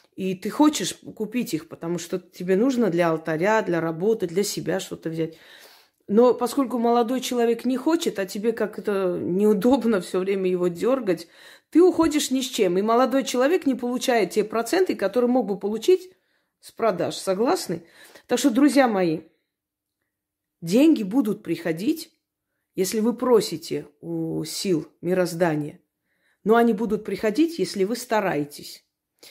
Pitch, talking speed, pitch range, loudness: 215 Hz, 145 wpm, 180-250 Hz, -23 LUFS